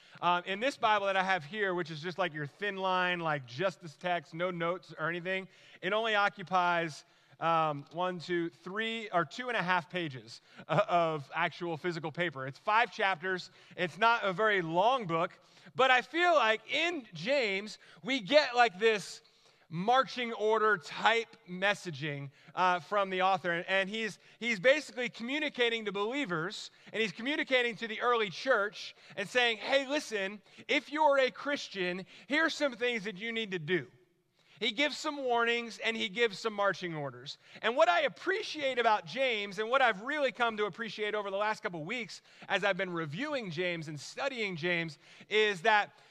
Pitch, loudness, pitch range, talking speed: 200 Hz, -31 LUFS, 175-230 Hz, 175 wpm